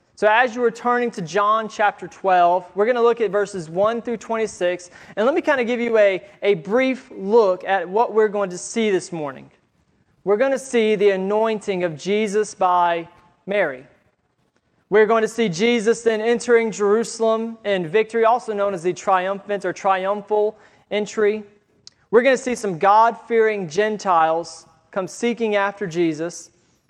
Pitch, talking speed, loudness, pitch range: 205 Hz, 170 wpm, -20 LUFS, 190-225 Hz